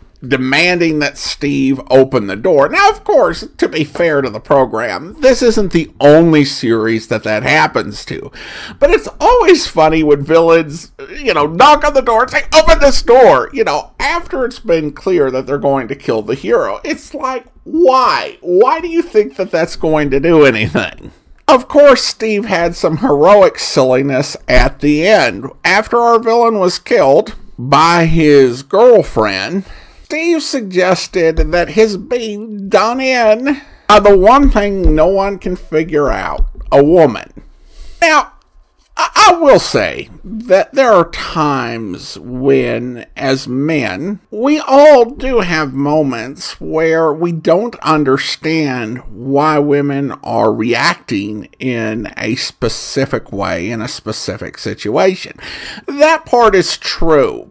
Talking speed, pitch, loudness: 145 wpm, 180 Hz, -12 LUFS